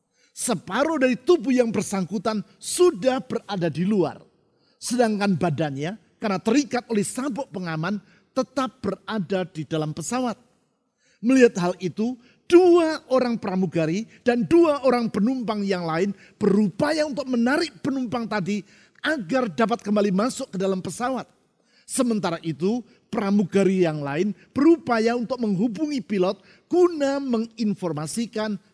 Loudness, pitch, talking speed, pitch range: -23 LUFS, 220 Hz, 115 wpm, 195-255 Hz